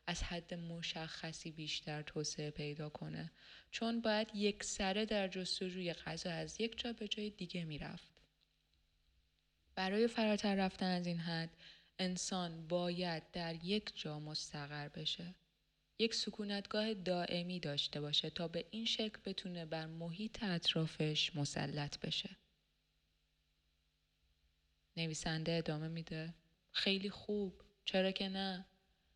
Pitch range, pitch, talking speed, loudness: 155-195 Hz, 170 Hz, 115 wpm, -40 LUFS